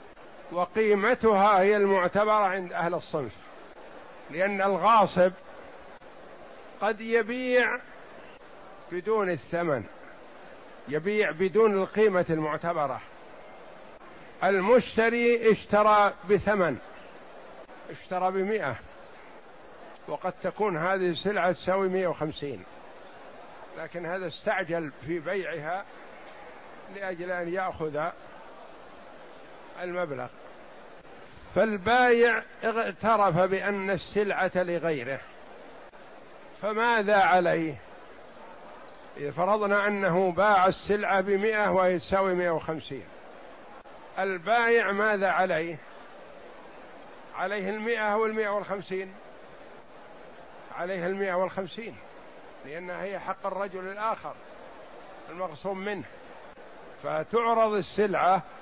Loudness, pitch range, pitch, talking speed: -26 LUFS, 180-210 Hz, 190 Hz, 75 wpm